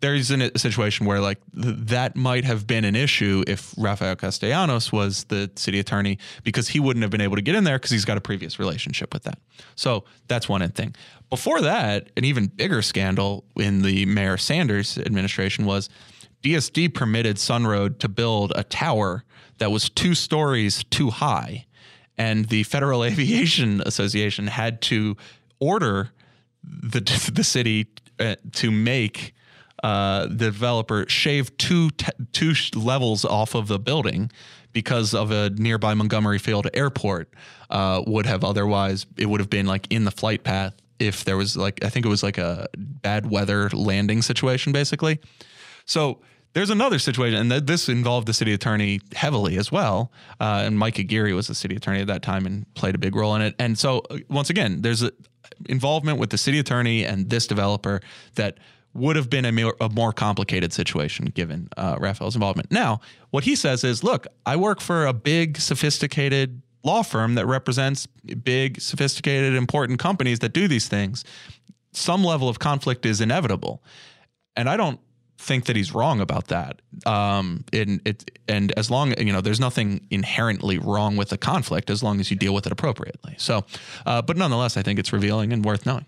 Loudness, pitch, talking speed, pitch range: -23 LUFS, 110 Hz, 185 wpm, 100-130 Hz